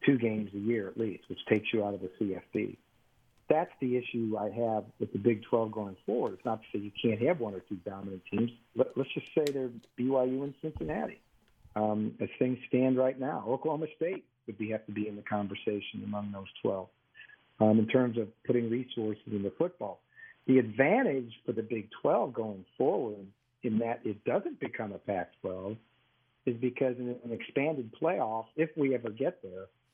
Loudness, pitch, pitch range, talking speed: -33 LUFS, 115 Hz, 105-125 Hz, 200 wpm